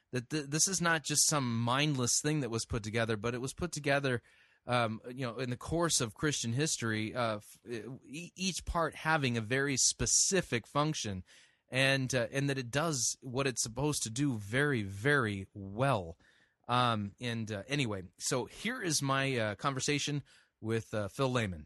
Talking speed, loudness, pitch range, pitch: 170 wpm, -32 LUFS, 115-145 Hz, 130 Hz